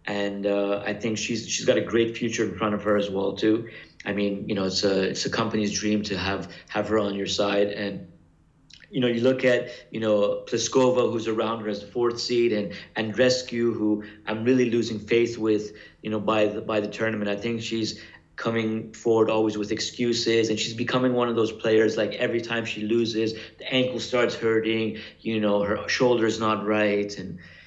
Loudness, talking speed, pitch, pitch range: -25 LUFS, 210 wpm, 110 Hz, 105-115 Hz